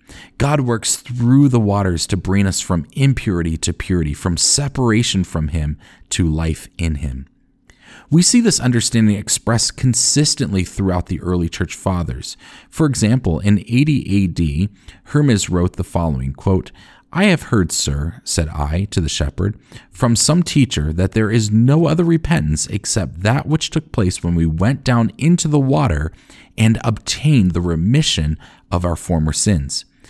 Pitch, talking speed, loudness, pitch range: 100 Hz, 160 wpm, -17 LUFS, 85-125 Hz